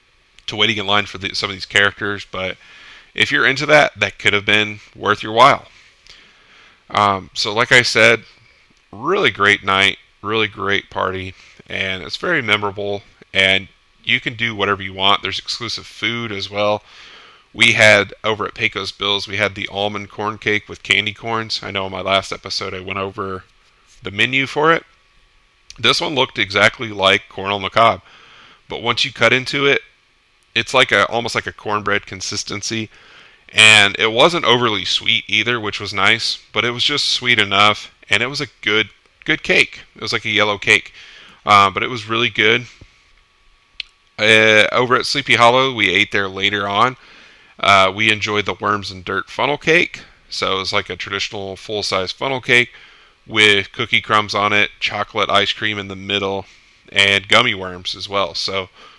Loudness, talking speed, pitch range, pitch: -16 LUFS, 180 wpm, 95-110 Hz, 105 Hz